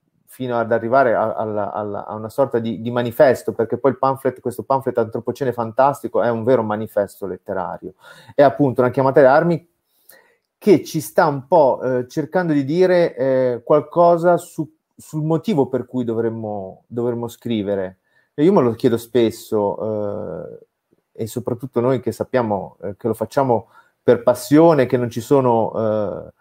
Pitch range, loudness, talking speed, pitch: 115-140 Hz, -19 LUFS, 165 wpm, 125 Hz